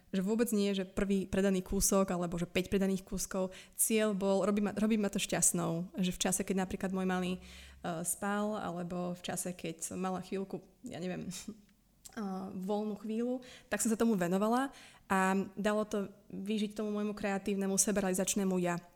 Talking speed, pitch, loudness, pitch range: 175 wpm, 195 Hz, -34 LUFS, 185-210 Hz